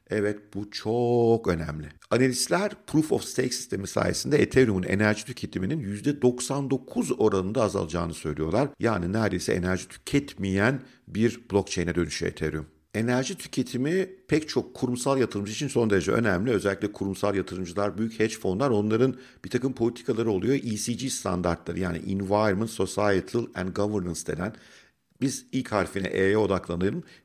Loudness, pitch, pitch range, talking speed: -27 LUFS, 105 Hz, 95-125 Hz, 130 wpm